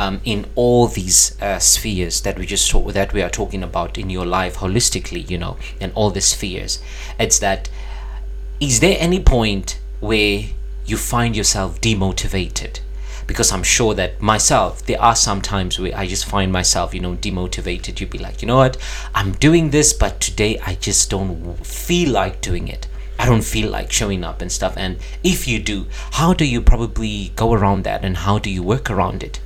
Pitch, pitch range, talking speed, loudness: 100 Hz, 90-110 Hz, 200 wpm, -18 LUFS